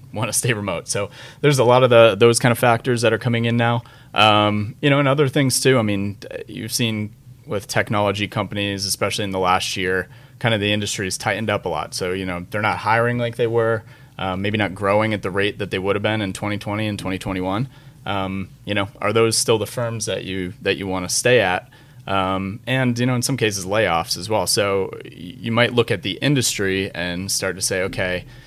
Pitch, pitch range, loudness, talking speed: 105 Hz, 100-120 Hz, -20 LUFS, 230 wpm